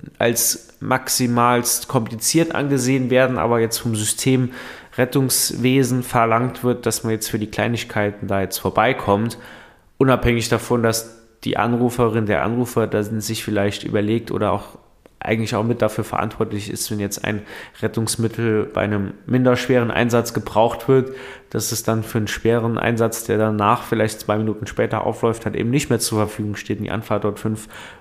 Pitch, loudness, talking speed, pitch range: 115 Hz, -20 LUFS, 165 wpm, 110-120 Hz